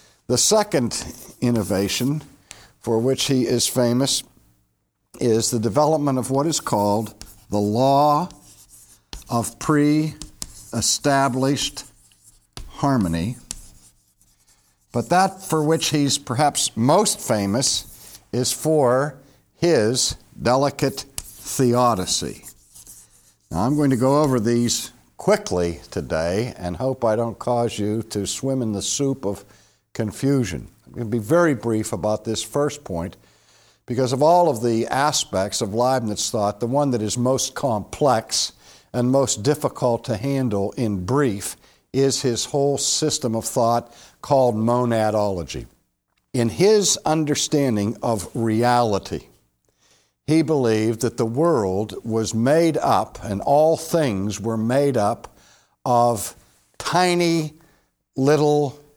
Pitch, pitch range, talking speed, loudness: 120 Hz, 110-140 Hz, 120 wpm, -21 LUFS